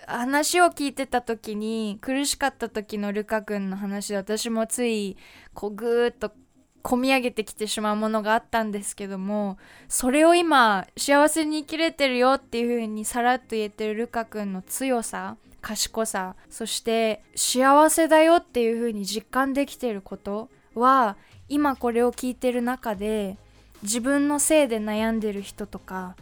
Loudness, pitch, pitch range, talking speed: -24 LUFS, 230 Hz, 210-265 Hz, 305 characters per minute